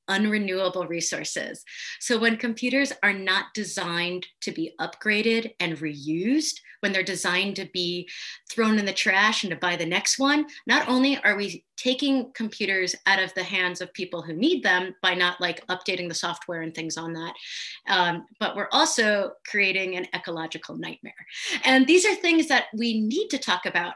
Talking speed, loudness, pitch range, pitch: 180 wpm, -24 LUFS, 180-230 Hz, 195 Hz